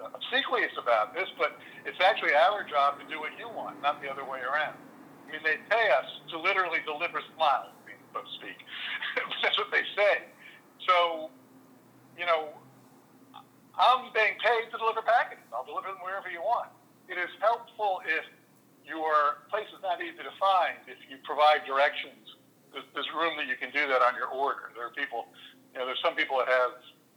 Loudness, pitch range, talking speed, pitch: -28 LUFS, 145-210 Hz, 185 wpm, 155 Hz